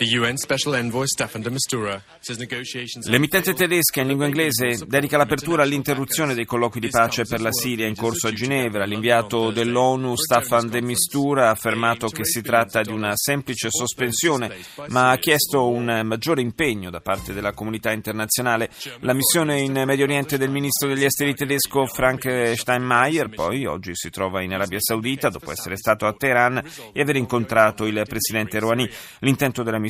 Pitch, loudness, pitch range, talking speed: 120 Hz, -21 LUFS, 110-135 Hz, 155 wpm